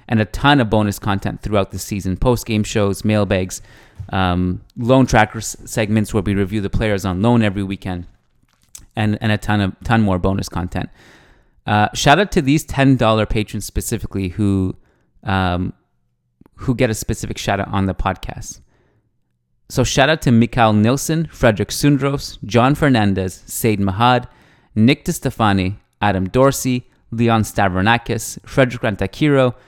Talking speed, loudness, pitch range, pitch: 150 wpm, -17 LUFS, 100-125 Hz, 110 Hz